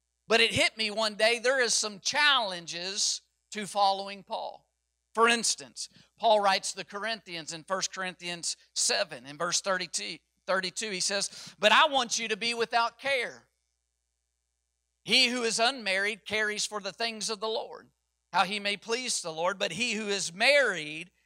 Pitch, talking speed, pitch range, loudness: 200 Hz, 165 wpm, 175-225 Hz, -28 LUFS